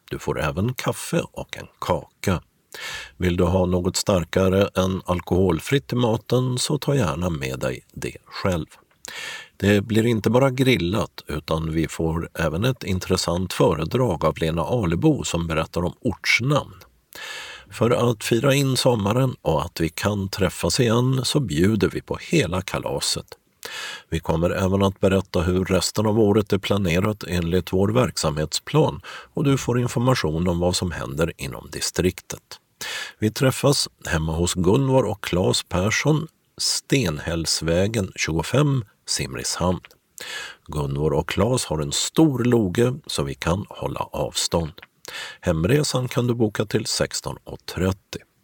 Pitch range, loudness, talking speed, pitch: 85-125 Hz, -22 LUFS, 140 wpm, 95 Hz